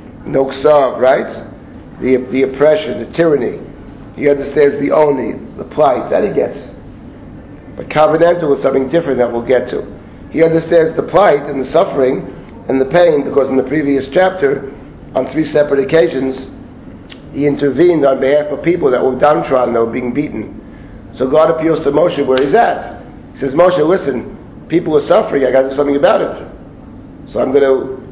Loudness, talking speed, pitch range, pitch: -13 LUFS, 175 wpm, 130-155 Hz, 140 Hz